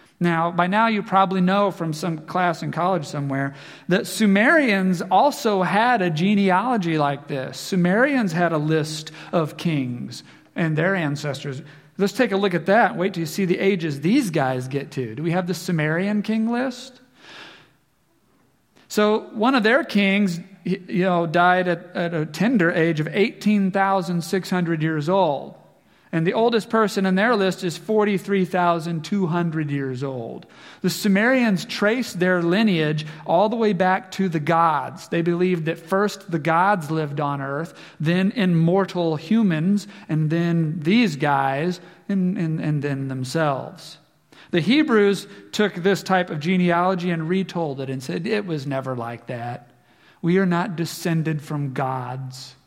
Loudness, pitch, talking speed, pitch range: -21 LUFS, 175 Hz, 155 wpm, 160-195 Hz